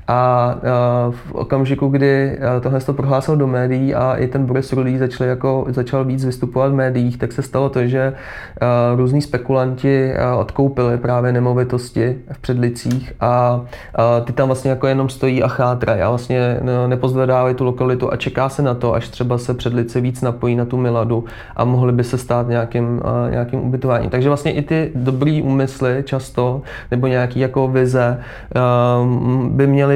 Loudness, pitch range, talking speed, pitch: -17 LUFS, 120-130 Hz, 165 wpm, 125 Hz